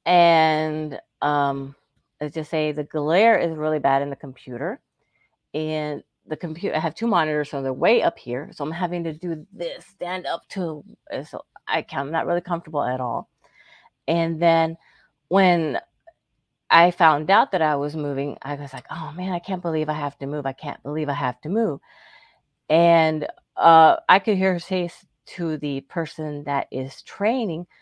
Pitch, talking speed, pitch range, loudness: 155 Hz, 185 wpm, 145-175 Hz, -22 LUFS